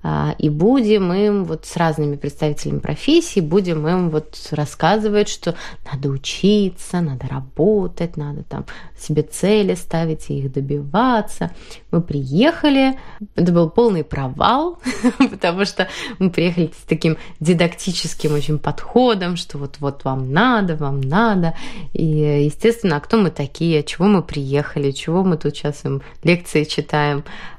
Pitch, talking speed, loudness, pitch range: 165 Hz, 135 wpm, -19 LUFS, 145-205 Hz